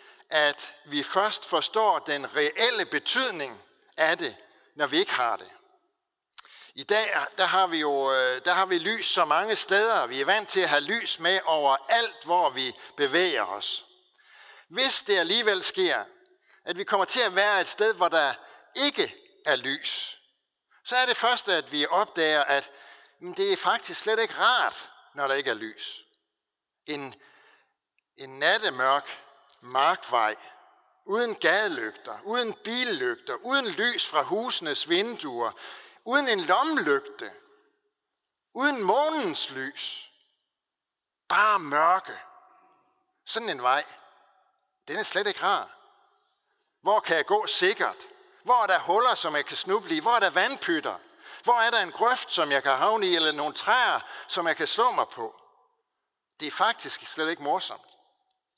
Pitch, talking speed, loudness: 260 Hz, 155 wpm, -25 LUFS